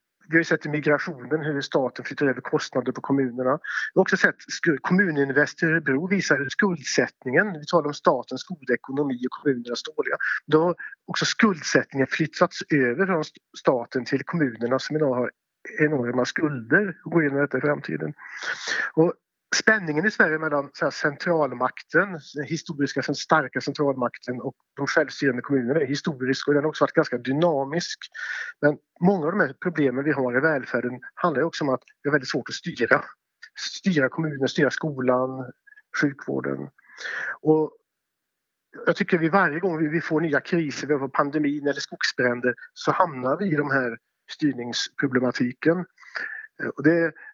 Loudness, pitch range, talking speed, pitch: -24 LUFS, 130-165 Hz, 155 wpm, 150 Hz